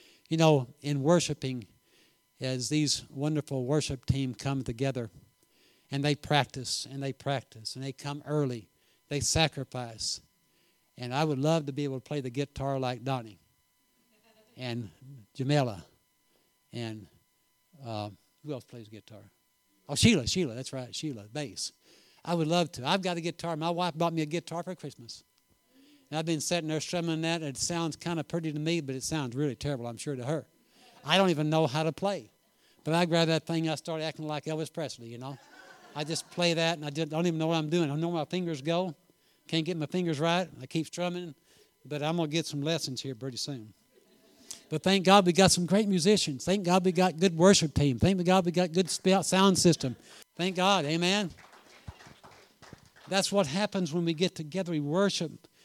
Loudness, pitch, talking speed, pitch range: -29 LUFS, 155 Hz, 195 wpm, 135-175 Hz